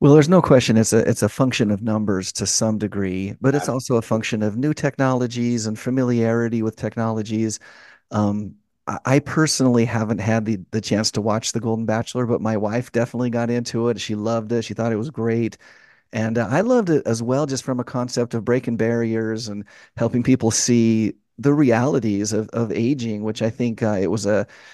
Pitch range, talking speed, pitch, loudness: 110-125 Hz, 205 wpm, 115 Hz, -21 LUFS